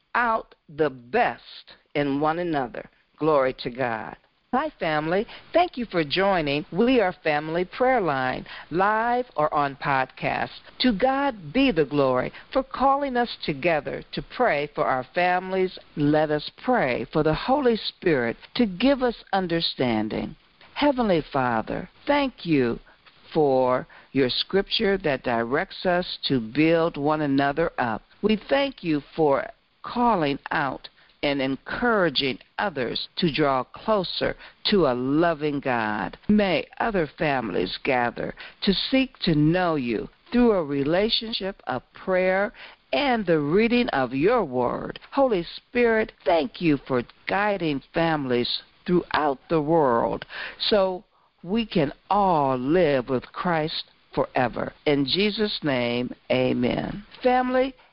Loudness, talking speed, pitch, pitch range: -24 LUFS, 125 wpm, 170 Hz, 145-225 Hz